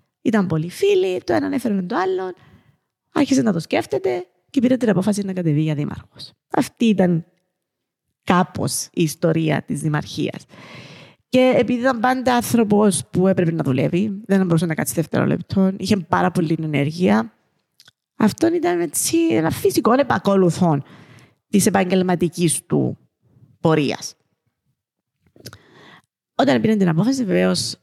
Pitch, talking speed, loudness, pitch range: 190 Hz, 130 wpm, -19 LUFS, 170-250 Hz